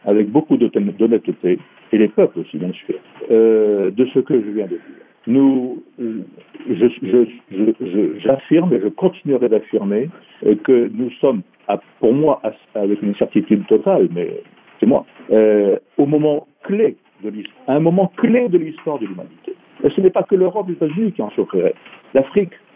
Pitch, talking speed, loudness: 145 Hz, 175 wpm, -17 LUFS